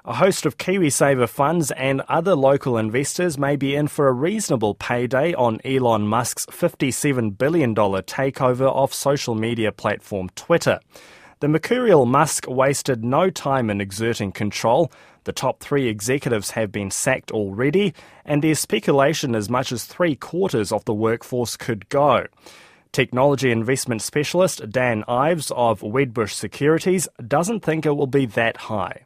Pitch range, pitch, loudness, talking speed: 115-150 Hz, 135 Hz, -21 LUFS, 150 wpm